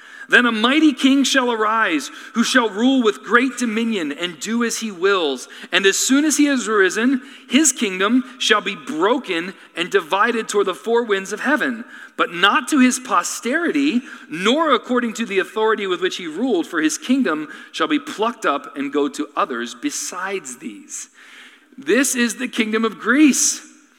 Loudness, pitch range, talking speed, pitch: -18 LUFS, 220-290 Hz, 175 wpm, 245 Hz